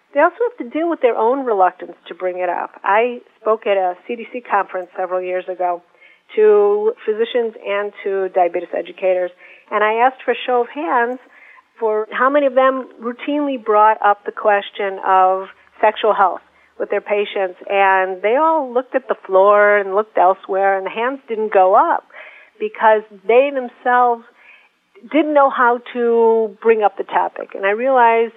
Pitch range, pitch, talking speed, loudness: 195-255 Hz, 220 Hz, 175 wpm, -17 LUFS